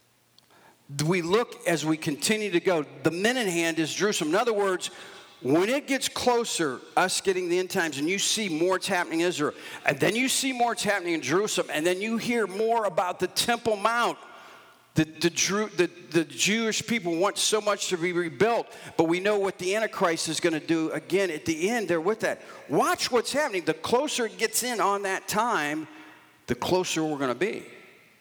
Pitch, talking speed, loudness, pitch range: 190 Hz, 210 wpm, -26 LUFS, 165-225 Hz